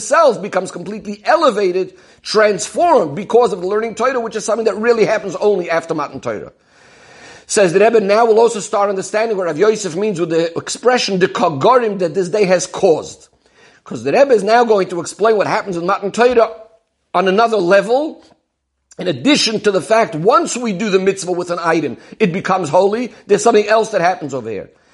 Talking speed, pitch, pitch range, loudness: 190 wpm, 210 Hz, 190-225 Hz, -15 LUFS